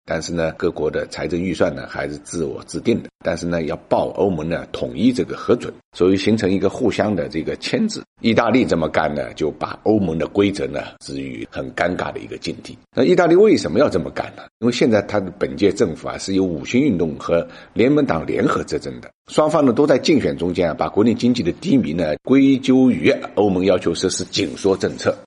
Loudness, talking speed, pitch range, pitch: -19 LUFS, 330 characters per minute, 80-105 Hz, 90 Hz